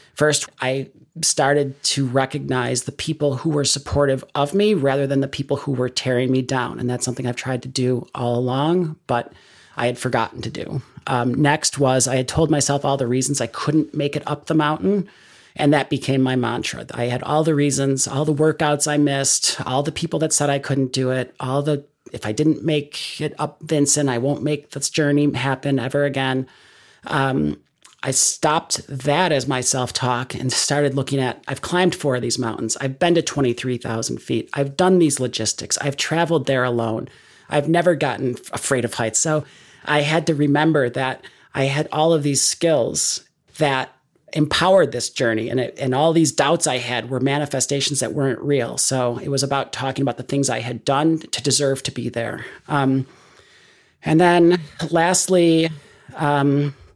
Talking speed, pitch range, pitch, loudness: 190 wpm, 130-150 Hz, 140 Hz, -20 LUFS